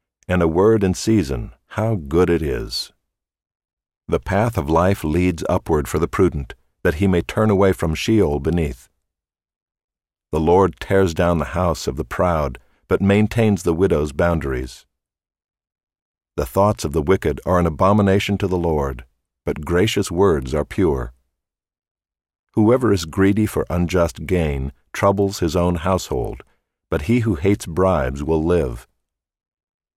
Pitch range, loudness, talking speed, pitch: 75-100 Hz, -19 LUFS, 145 wpm, 90 Hz